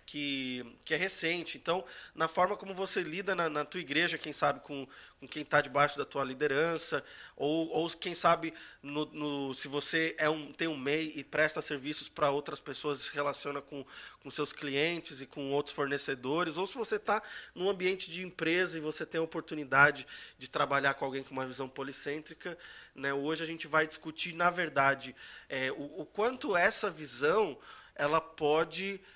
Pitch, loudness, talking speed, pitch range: 155 Hz, -32 LUFS, 185 wpm, 140-170 Hz